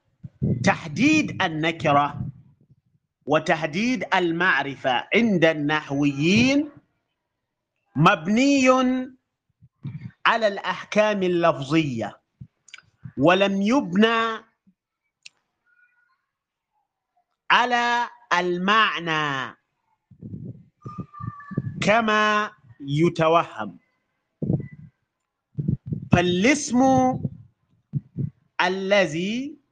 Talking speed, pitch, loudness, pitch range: 35 wpm, 185 Hz, -22 LUFS, 150-240 Hz